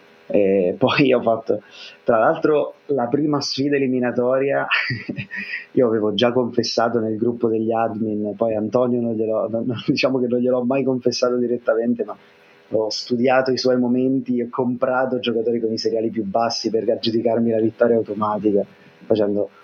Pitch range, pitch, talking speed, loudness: 110-125 Hz, 120 Hz, 155 wpm, -20 LUFS